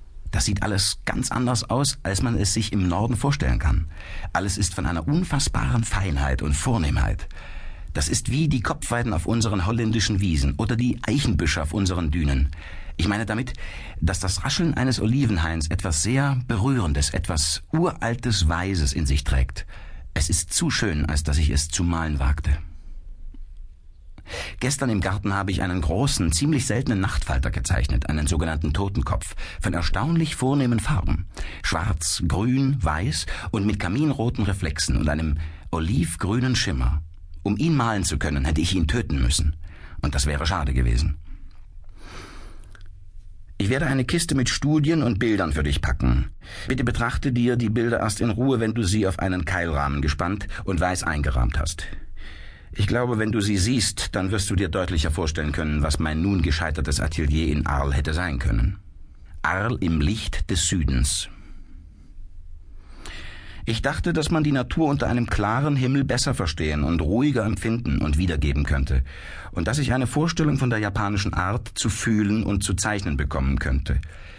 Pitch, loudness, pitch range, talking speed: 90 Hz, -23 LUFS, 80-115 Hz, 160 wpm